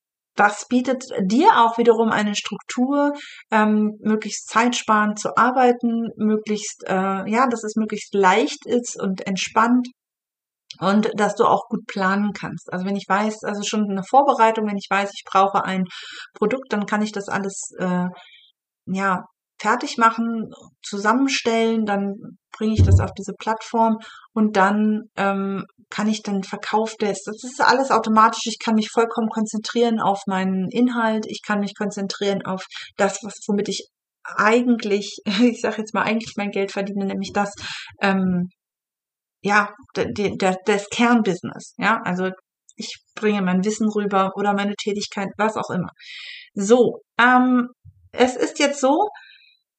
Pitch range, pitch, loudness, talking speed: 200-230 Hz, 215 Hz, -21 LUFS, 150 wpm